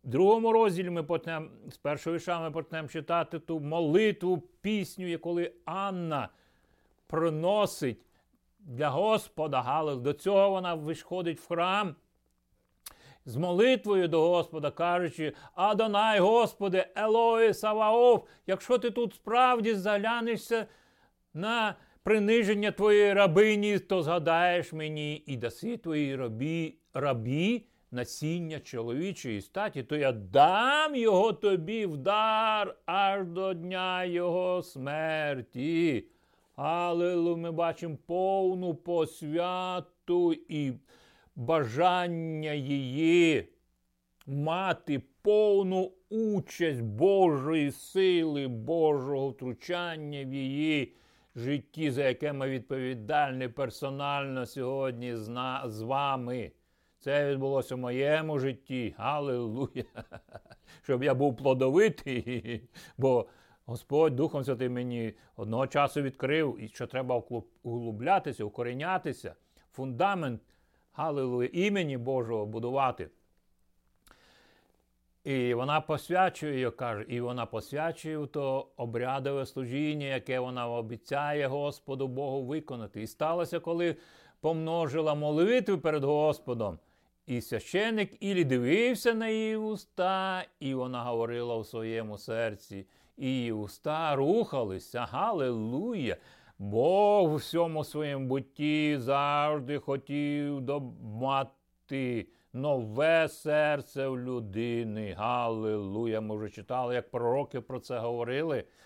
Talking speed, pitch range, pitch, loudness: 100 wpm, 125-175 Hz, 150 Hz, -30 LUFS